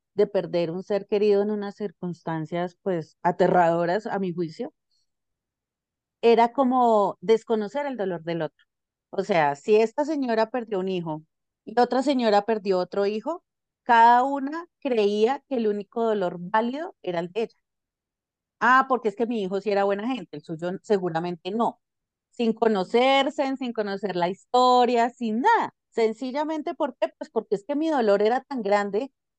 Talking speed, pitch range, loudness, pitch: 165 wpm, 185-250 Hz, -24 LUFS, 215 Hz